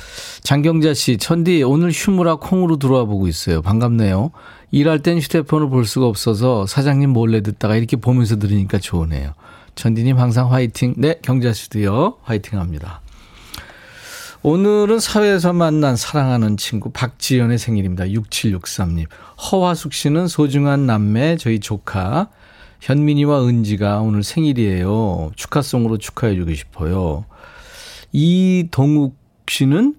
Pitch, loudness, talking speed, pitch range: 125 Hz, -17 LUFS, 305 characters per minute, 105-155 Hz